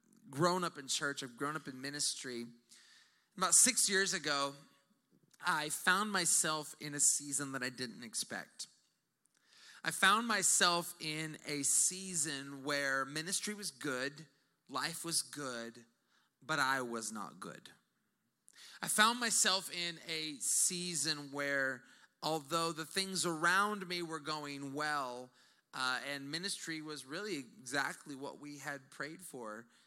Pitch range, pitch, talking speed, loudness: 140-175 Hz, 150 Hz, 135 wpm, -35 LUFS